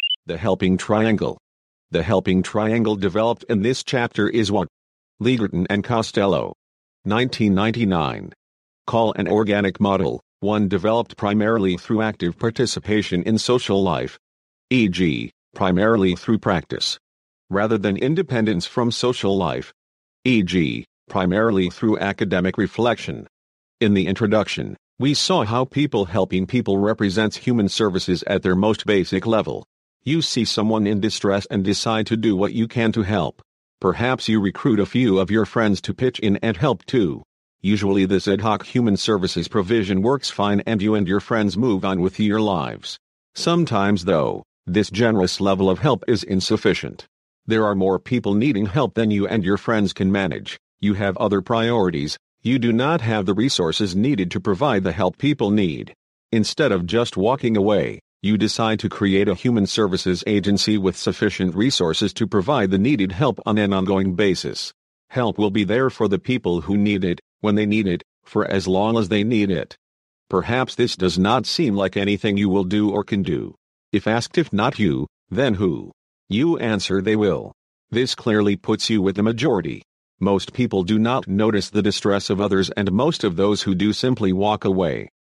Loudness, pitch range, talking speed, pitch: -20 LUFS, 95-110 Hz, 170 wpm, 105 Hz